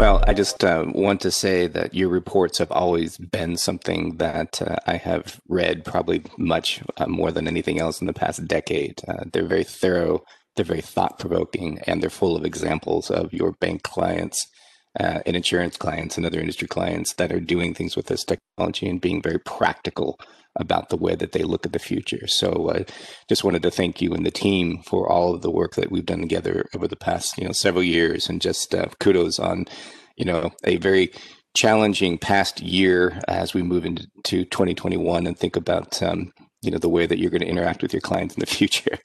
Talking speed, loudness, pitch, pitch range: 210 wpm, -23 LUFS, 90 Hz, 85-95 Hz